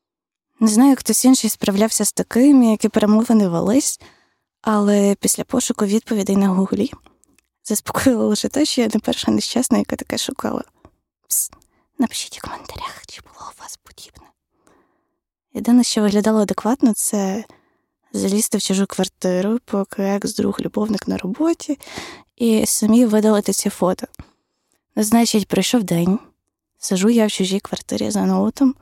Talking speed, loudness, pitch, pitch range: 135 wpm, -18 LUFS, 220 Hz, 205-245 Hz